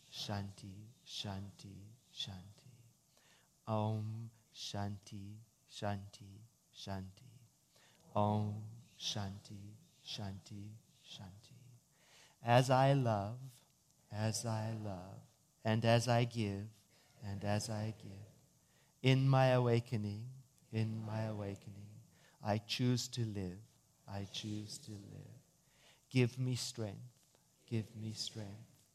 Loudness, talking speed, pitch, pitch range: -38 LUFS, 95 wpm, 110 Hz, 105-130 Hz